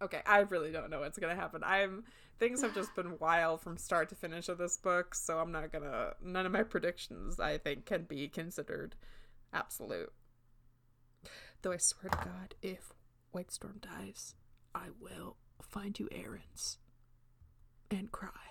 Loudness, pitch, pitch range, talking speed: -37 LUFS, 175 Hz, 155-195 Hz, 165 wpm